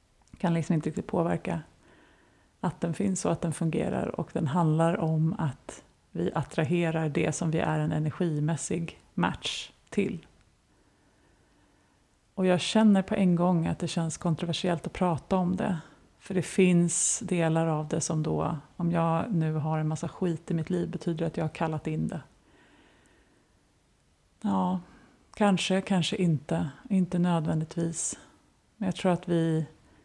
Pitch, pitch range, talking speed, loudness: 170 Hz, 160-180 Hz, 155 wpm, -28 LUFS